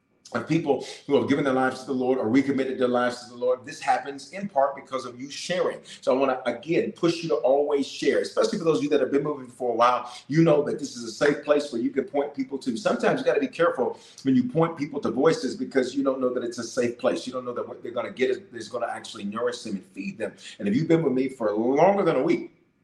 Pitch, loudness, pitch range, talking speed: 135 Hz, -25 LUFS, 125-160 Hz, 295 wpm